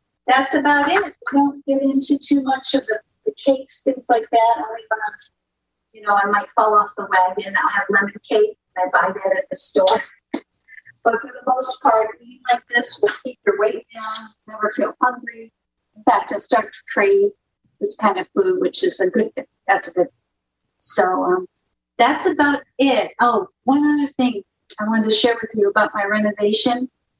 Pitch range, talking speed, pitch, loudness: 215-280 Hz, 195 wpm, 245 Hz, -19 LUFS